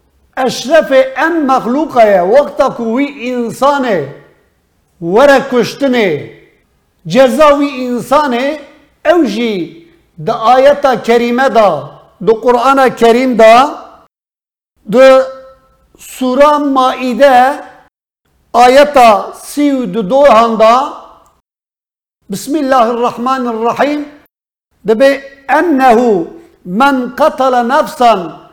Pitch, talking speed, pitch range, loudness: 260 Hz, 75 wpm, 235-285 Hz, -10 LUFS